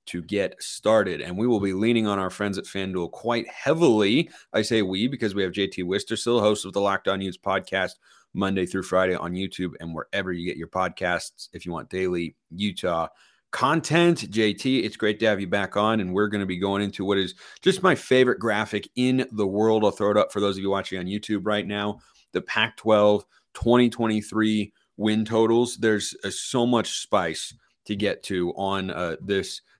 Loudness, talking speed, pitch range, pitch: -24 LUFS, 200 wpm, 95-110 Hz, 100 Hz